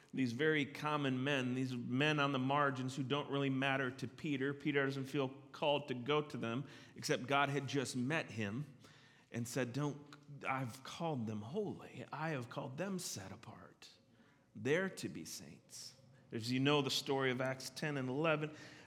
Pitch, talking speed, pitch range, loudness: 135 Hz, 180 wpm, 130-145 Hz, -39 LUFS